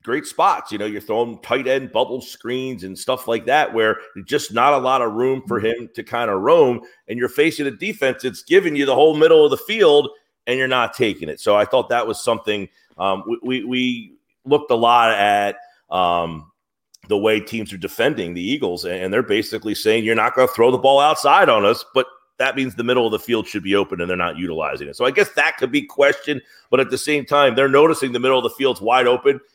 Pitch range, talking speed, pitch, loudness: 110-145 Hz, 240 wpm, 130 Hz, -18 LUFS